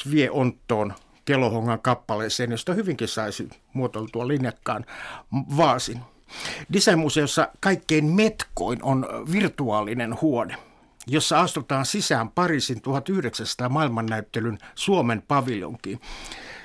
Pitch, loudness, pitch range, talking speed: 130 Hz, -24 LUFS, 115-155 Hz, 85 wpm